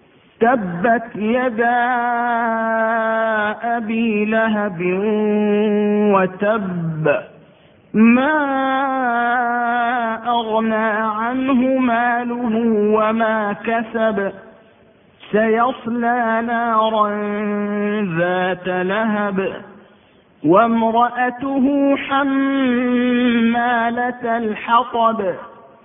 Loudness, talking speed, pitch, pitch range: -18 LUFS, 40 wpm, 230 Hz, 210-240 Hz